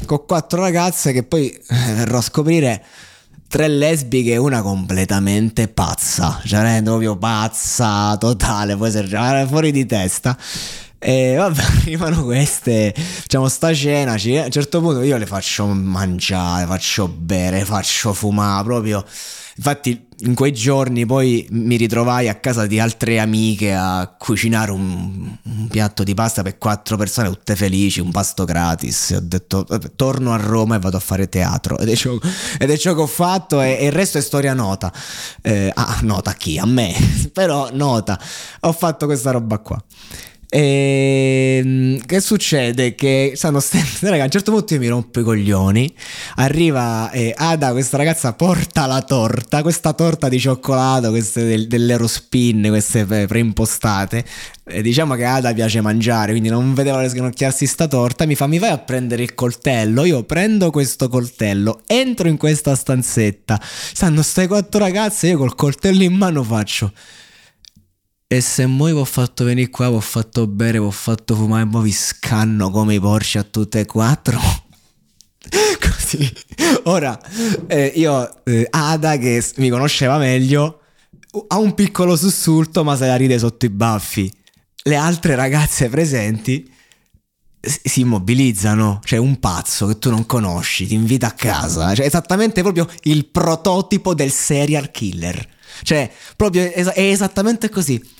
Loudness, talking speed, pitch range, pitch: -17 LUFS, 160 wpm, 110-150 Hz, 125 Hz